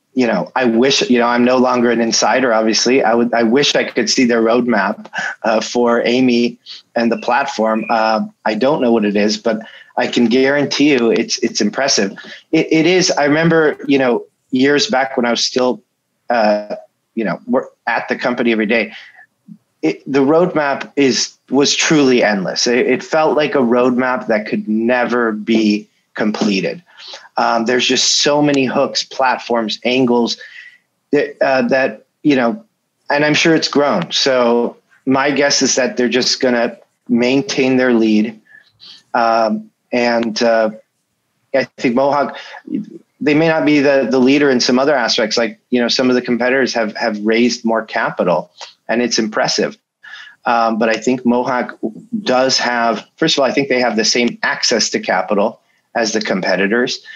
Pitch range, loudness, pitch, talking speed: 115-140 Hz, -15 LUFS, 125 Hz, 170 wpm